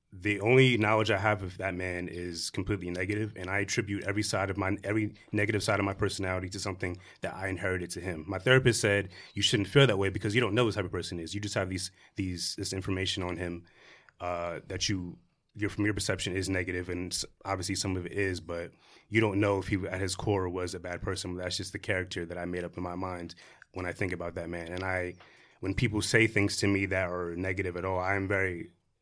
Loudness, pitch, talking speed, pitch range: -31 LUFS, 95 Hz, 245 wpm, 90-100 Hz